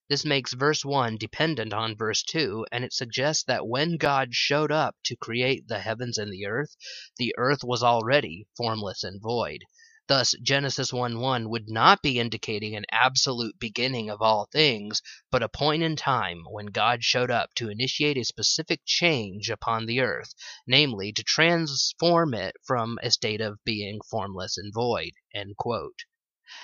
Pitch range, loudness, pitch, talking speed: 110-145 Hz, -25 LUFS, 120 Hz, 160 wpm